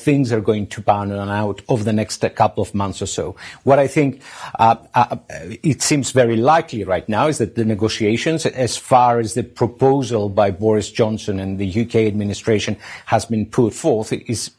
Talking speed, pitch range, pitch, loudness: 195 wpm, 105-125 Hz, 115 Hz, -18 LUFS